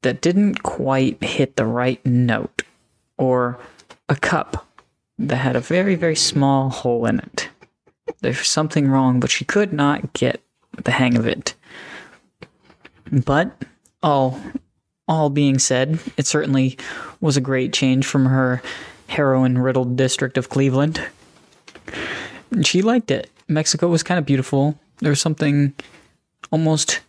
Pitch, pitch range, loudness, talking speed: 140 Hz, 130-155 Hz, -19 LUFS, 135 wpm